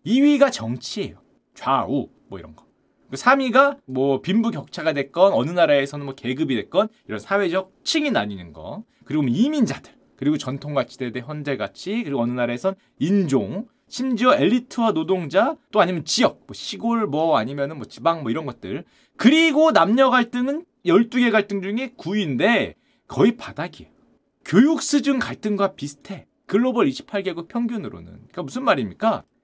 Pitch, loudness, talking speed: 200 Hz, -21 LUFS, 330 characters per minute